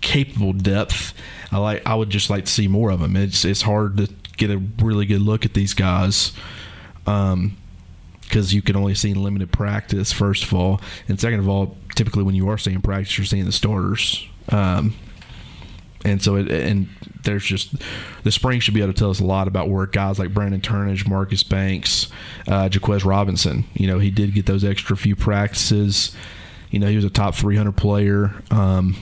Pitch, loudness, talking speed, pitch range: 100 Hz, -20 LUFS, 200 wpm, 95-105 Hz